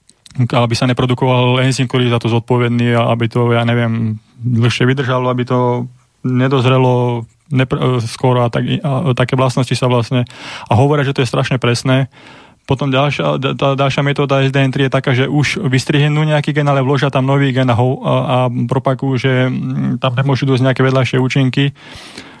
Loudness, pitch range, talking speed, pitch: -14 LUFS, 125-135 Hz, 175 wpm, 130 Hz